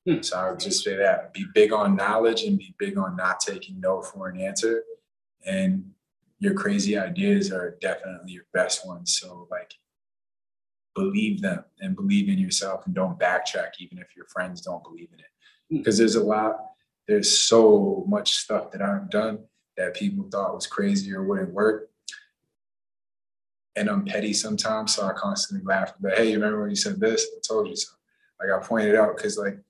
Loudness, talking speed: -24 LUFS, 190 wpm